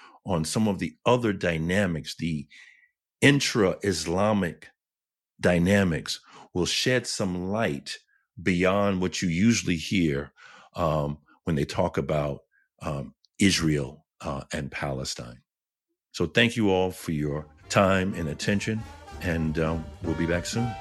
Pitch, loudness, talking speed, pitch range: 85 Hz, -26 LUFS, 125 wpm, 80-100 Hz